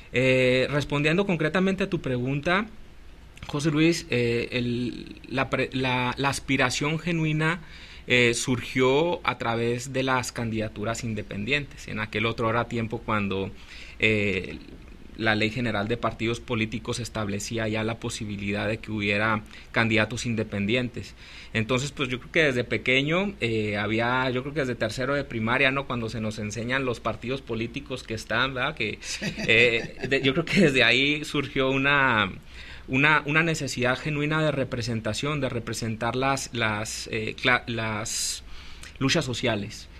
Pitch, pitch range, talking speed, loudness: 120 Hz, 110-135 Hz, 145 wpm, -25 LUFS